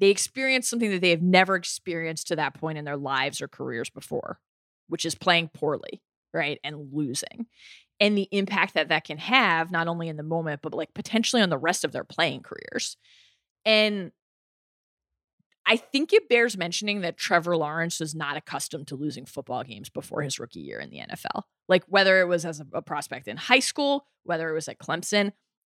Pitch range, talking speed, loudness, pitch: 155-205 Hz, 195 wpm, -25 LUFS, 170 Hz